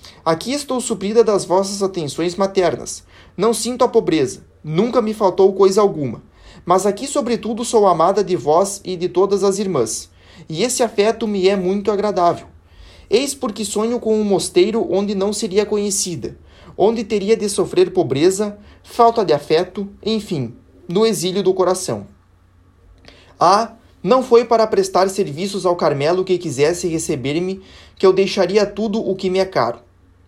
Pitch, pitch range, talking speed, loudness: 195 Hz, 170-220 Hz, 155 wpm, -17 LUFS